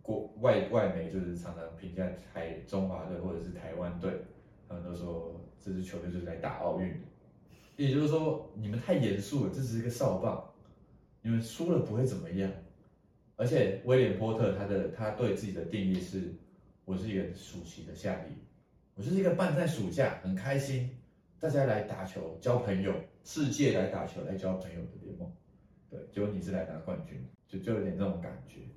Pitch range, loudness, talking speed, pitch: 90-125 Hz, -34 LUFS, 280 characters per minute, 95 Hz